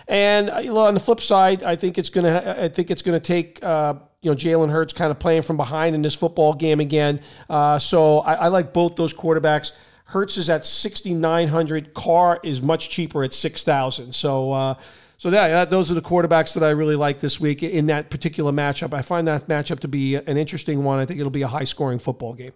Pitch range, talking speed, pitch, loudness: 145-170 Hz, 210 wpm, 160 Hz, -20 LUFS